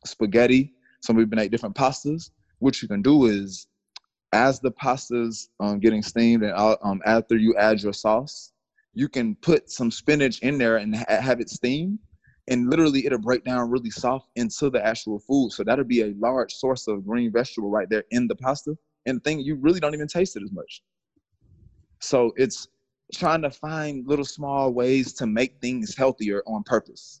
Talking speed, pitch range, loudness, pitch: 190 wpm, 110-140 Hz, -23 LUFS, 125 Hz